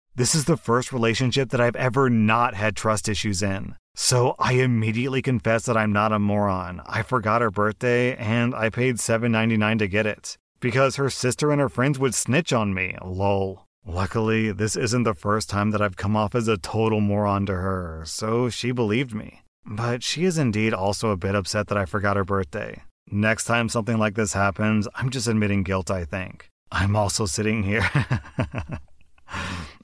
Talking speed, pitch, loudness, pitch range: 185 wpm, 110 Hz, -23 LUFS, 100-120 Hz